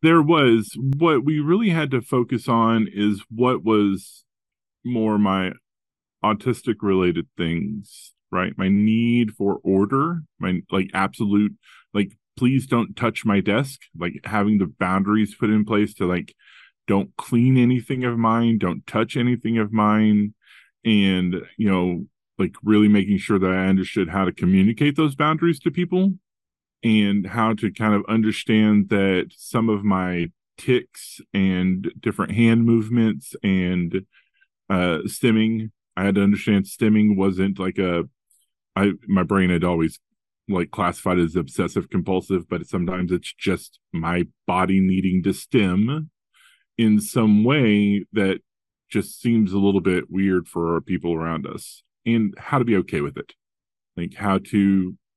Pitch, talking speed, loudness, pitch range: 105 Hz, 150 wpm, -21 LUFS, 95-115 Hz